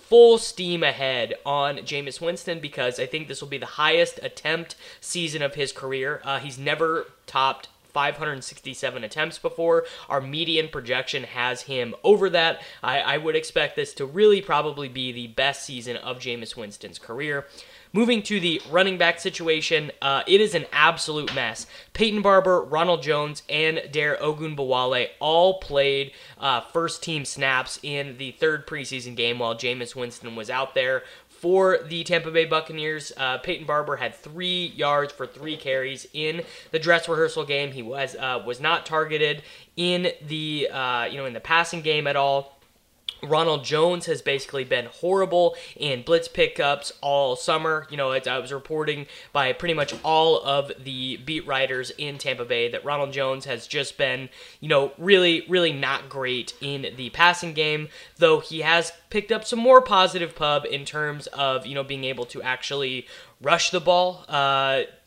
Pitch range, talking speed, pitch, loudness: 135-170 Hz, 170 wpm, 150 Hz, -23 LUFS